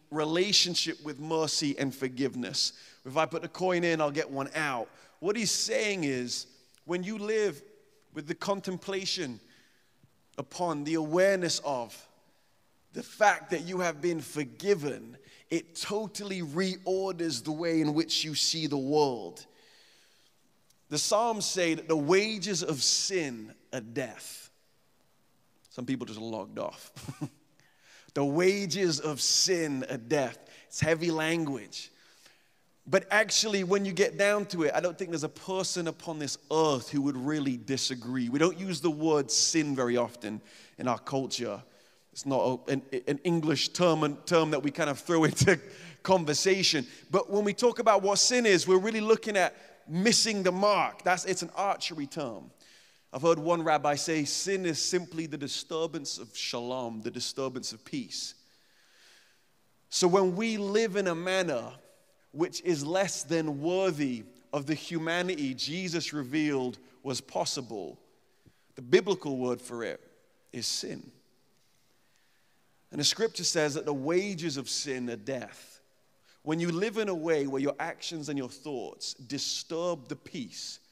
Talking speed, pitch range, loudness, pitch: 150 wpm, 140-185 Hz, -29 LUFS, 160 Hz